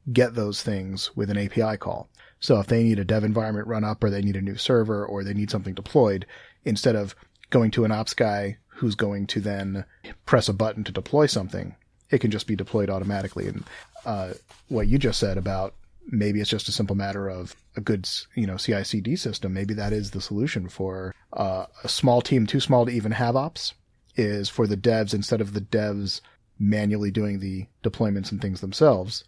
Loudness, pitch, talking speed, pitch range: -25 LUFS, 105 Hz, 205 wpm, 100-115 Hz